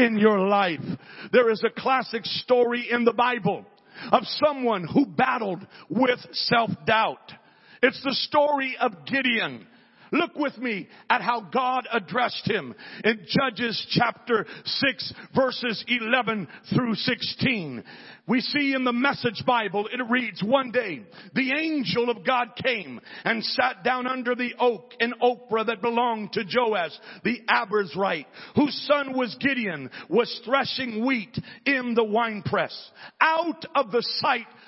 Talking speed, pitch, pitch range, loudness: 145 wpm, 240 Hz, 220-255 Hz, -24 LUFS